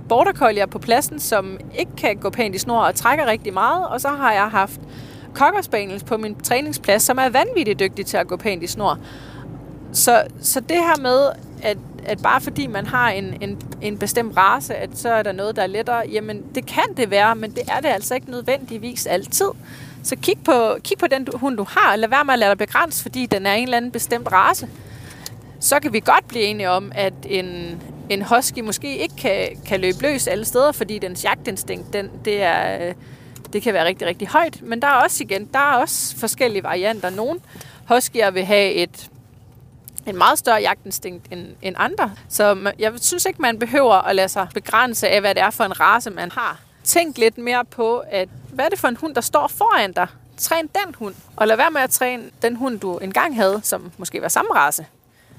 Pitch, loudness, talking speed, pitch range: 215 Hz, -19 LUFS, 220 wpm, 190-250 Hz